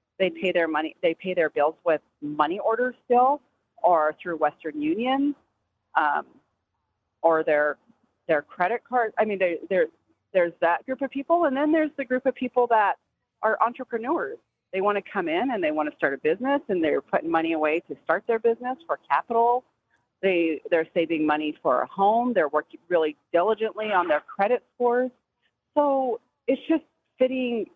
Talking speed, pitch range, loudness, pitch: 180 wpm, 165-260 Hz, -25 LUFS, 220 Hz